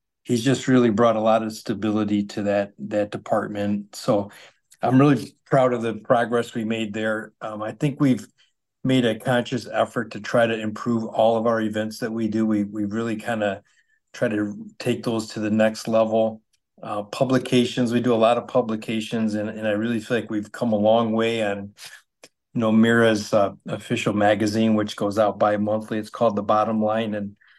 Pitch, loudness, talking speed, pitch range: 110 Hz, -22 LUFS, 195 wpm, 105-120 Hz